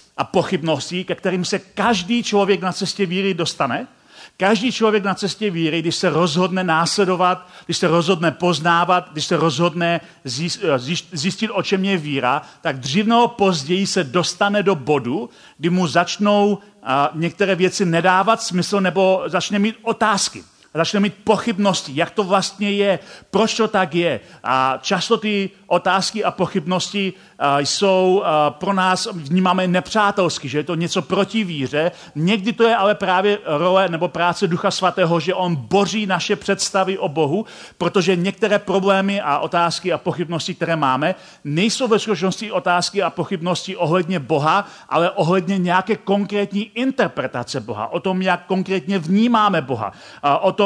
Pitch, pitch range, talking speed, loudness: 185 Hz, 170-200 Hz, 150 wpm, -19 LUFS